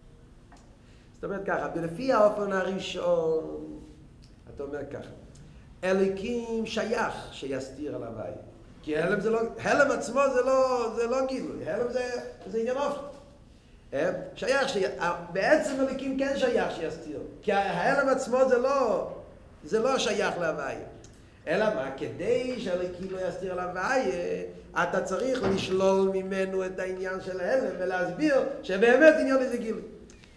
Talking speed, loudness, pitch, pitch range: 120 wpm, -28 LUFS, 205 Hz, 180-260 Hz